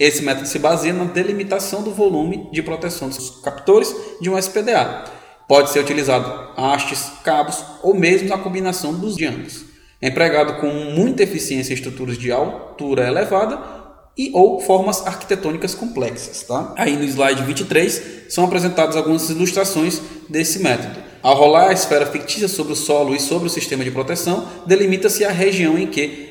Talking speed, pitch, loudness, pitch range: 160 wpm, 160 Hz, -18 LUFS, 145-190 Hz